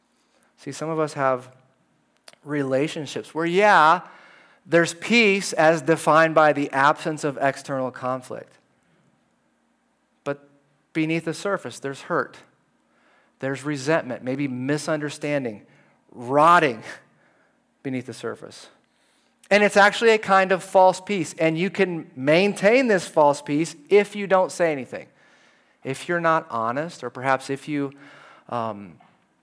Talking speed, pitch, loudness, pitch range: 125 wpm, 155 Hz, -21 LUFS, 140-175 Hz